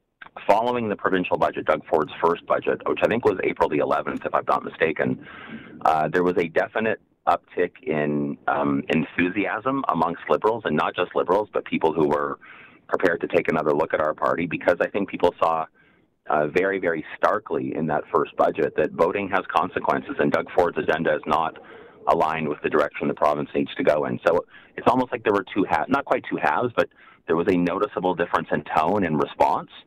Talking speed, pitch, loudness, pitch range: 200 wpm, 80 Hz, -23 LUFS, 70-95 Hz